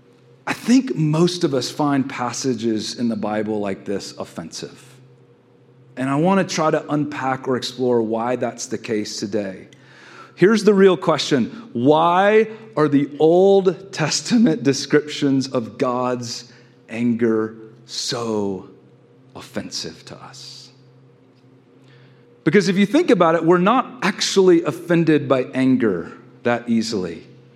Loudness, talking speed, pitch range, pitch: -19 LUFS, 125 wpm, 120-170 Hz, 130 Hz